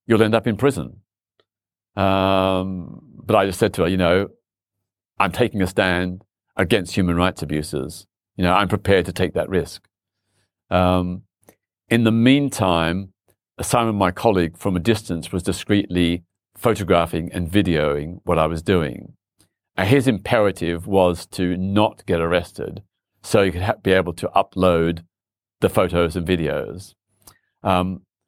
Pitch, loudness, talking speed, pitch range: 95 Hz, -20 LUFS, 150 wpm, 90-105 Hz